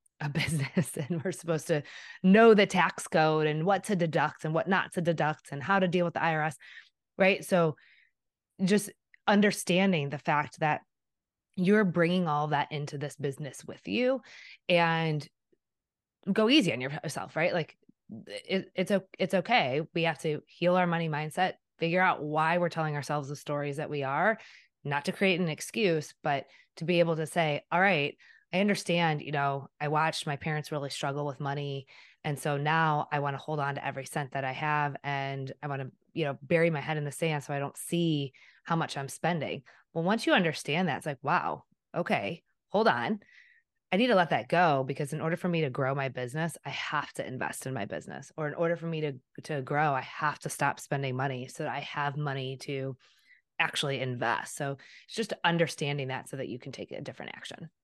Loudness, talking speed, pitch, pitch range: -30 LUFS, 205 wpm, 155 Hz, 145-175 Hz